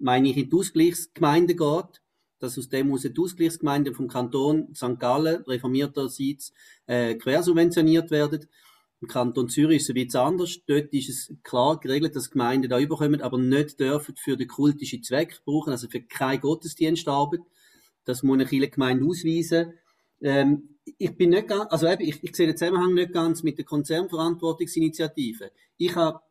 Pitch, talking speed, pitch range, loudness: 150 Hz, 165 wpm, 135-165 Hz, -24 LUFS